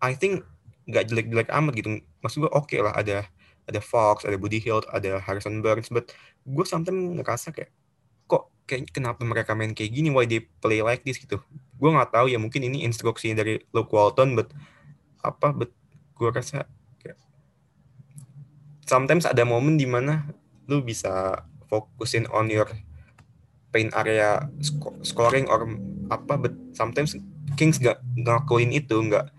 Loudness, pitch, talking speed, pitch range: -25 LUFS, 120 Hz, 155 wpm, 110-145 Hz